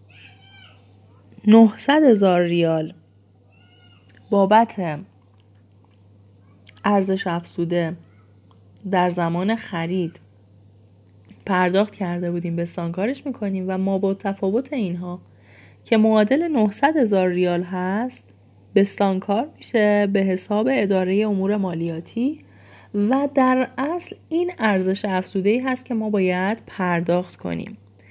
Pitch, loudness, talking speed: 185 Hz, -21 LUFS, 100 wpm